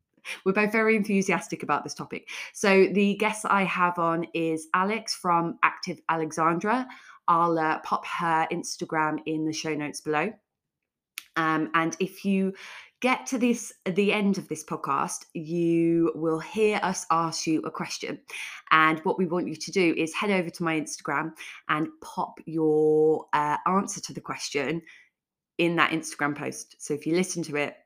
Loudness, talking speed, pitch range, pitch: -26 LUFS, 170 wpm, 155-190 Hz, 165 Hz